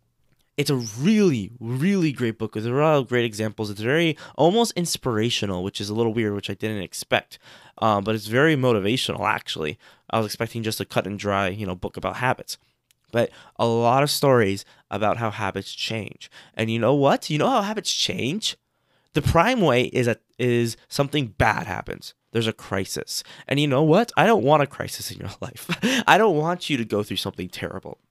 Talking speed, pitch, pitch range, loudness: 205 wpm, 120 Hz, 105-140 Hz, -23 LUFS